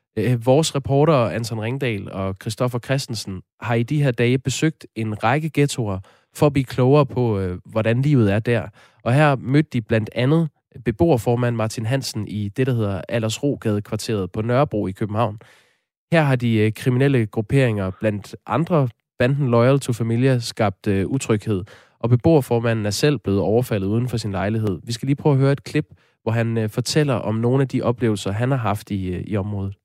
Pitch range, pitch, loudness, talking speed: 110-135 Hz, 120 Hz, -21 LUFS, 175 wpm